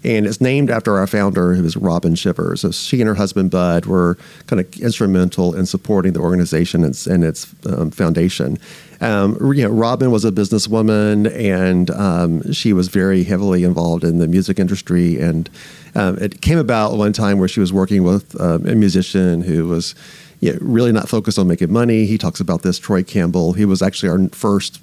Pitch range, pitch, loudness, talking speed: 90-110 Hz, 95 Hz, -16 LUFS, 205 wpm